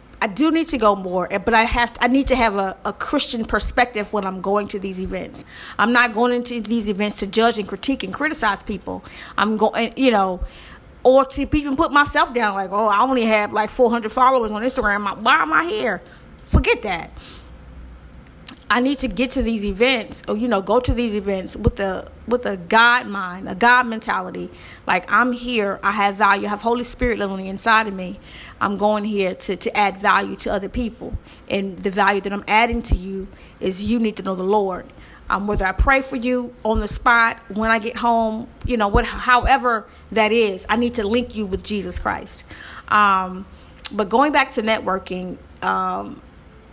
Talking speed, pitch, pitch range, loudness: 205 wpm, 215 Hz, 195-245 Hz, -19 LUFS